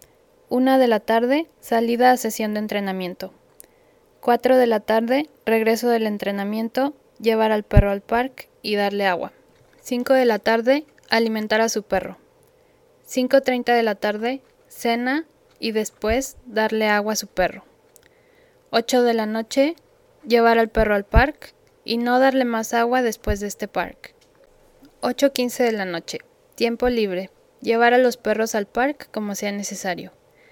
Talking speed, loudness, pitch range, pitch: 150 wpm, -21 LUFS, 215-270 Hz, 235 Hz